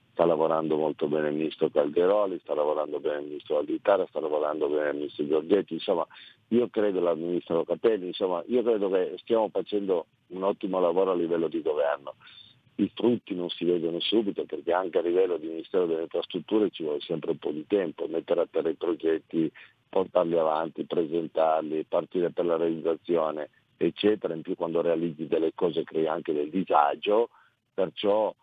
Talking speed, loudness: 175 wpm, -27 LUFS